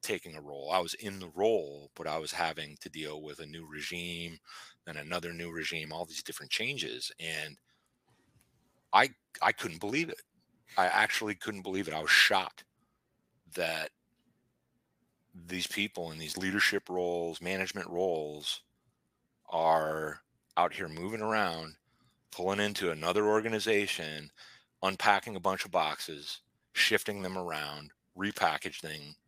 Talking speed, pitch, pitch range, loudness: 135 wpm, 85 Hz, 75-95 Hz, -32 LUFS